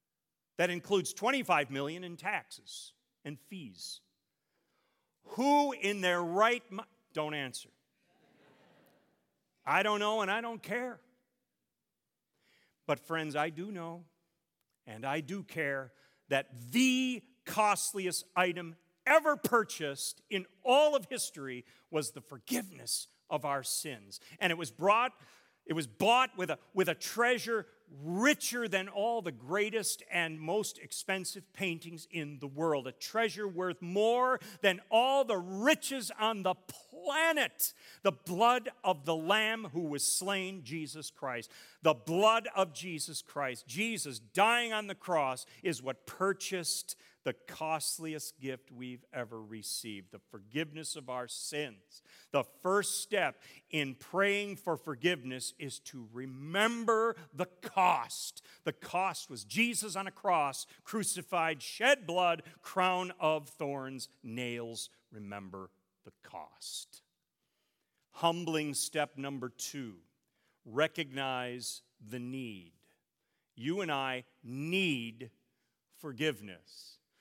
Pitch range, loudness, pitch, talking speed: 140-205 Hz, -33 LUFS, 170 Hz, 125 wpm